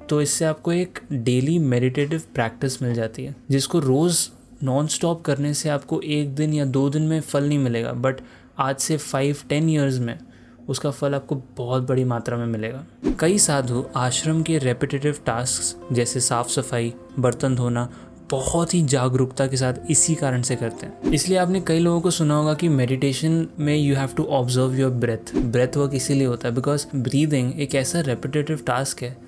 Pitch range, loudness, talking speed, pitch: 125-150 Hz, -22 LUFS, 185 wpm, 135 Hz